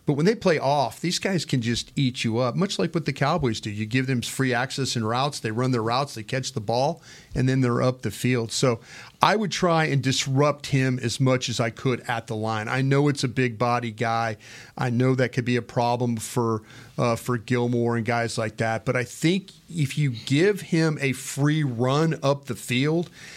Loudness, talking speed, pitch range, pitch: -24 LUFS, 230 wpm, 120-145 Hz, 130 Hz